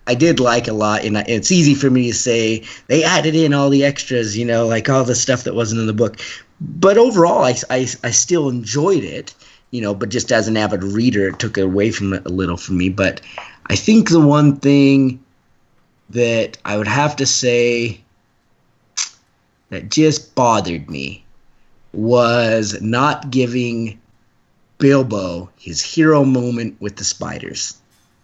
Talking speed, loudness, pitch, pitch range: 170 wpm, -16 LUFS, 120 Hz, 105-140 Hz